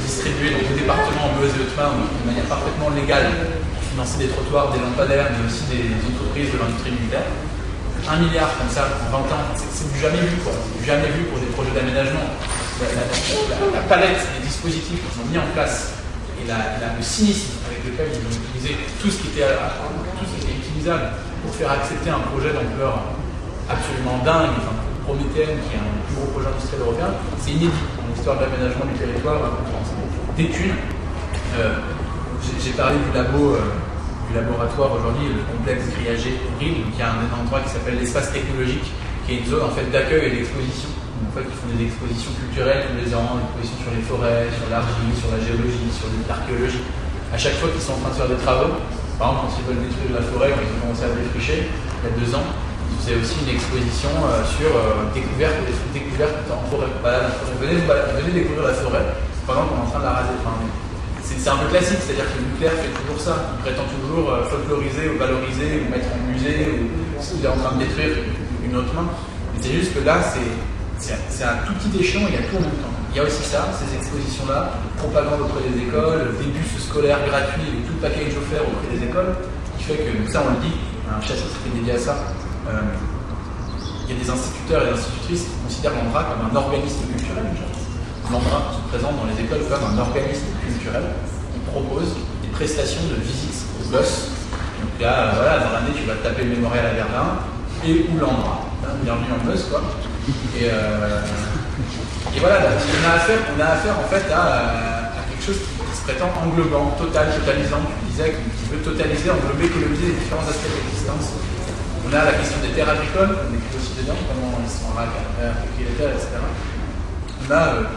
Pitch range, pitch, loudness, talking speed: 95-130 Hz, 115 Hz, -22 LUFS, 210 wpm